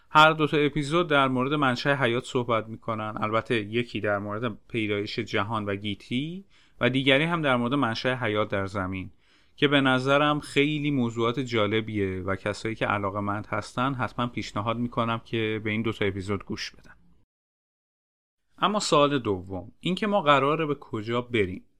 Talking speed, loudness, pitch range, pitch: 160 wpm, -26 LUFS, 105-140 Hz, 120 Hz